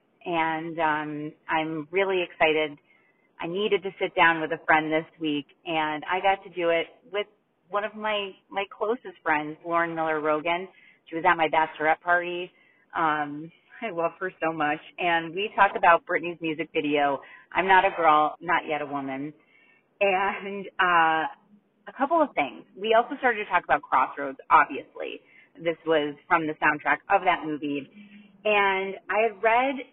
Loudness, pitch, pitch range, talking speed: -25 LUFS, 170 Hz, 155-200 Hz, 170 wpm